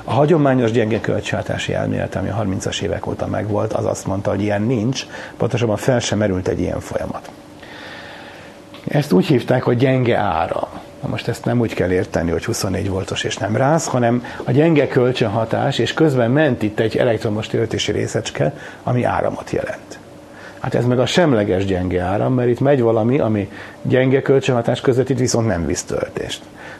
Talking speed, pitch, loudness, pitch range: 175 wpm, 115 Hz, -18 LUFS, 105-130 Hz